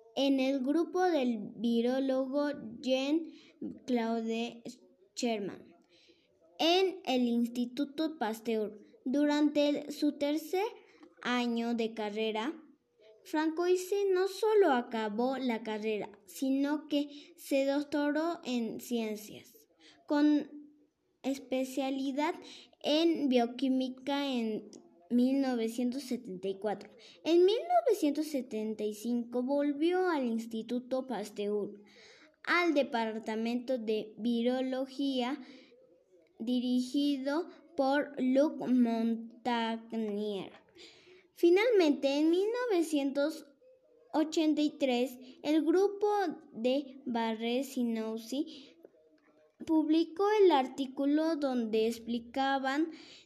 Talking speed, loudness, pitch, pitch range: 70 wpm, -32 LUFS, 270 Hz, 235-310 Hz